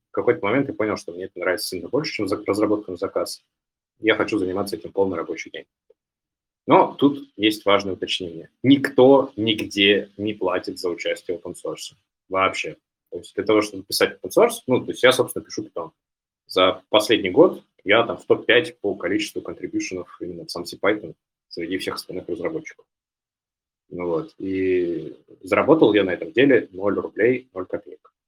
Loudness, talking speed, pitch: -21 LUFS, 170 wpm, 325 Hz